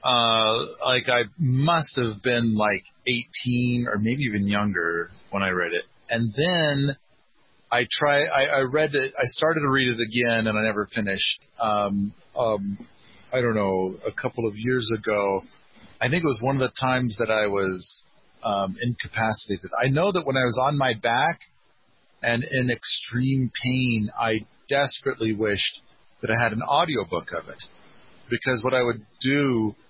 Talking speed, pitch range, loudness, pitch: 170 wpm, 105-130 Hz, -23 LUFS, 120 Hz